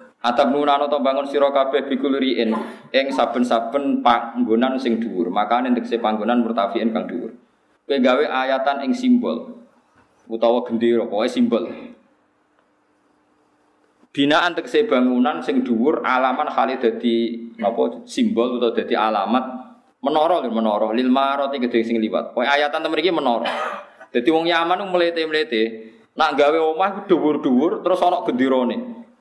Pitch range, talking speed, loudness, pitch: 115-165 Hz, 130 wpm, -20 LUFS, 135 Hz